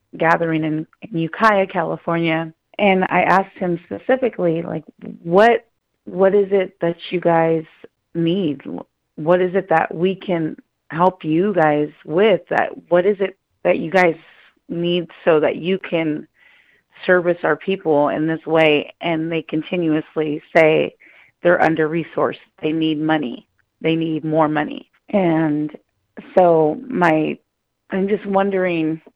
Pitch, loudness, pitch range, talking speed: 170 Hz, -18 LUFS, 160-190 Hz, 135 wpm